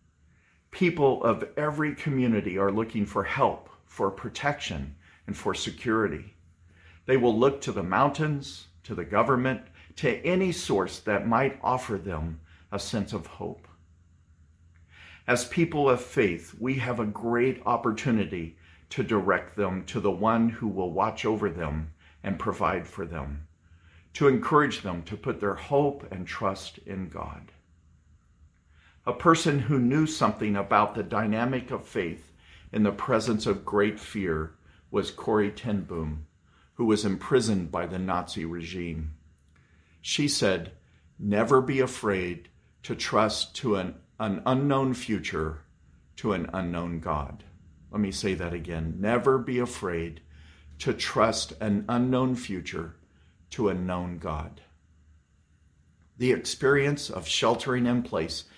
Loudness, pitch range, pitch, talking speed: -28 LUFS, 80-120 Hz, 95 Hz, 135 wpm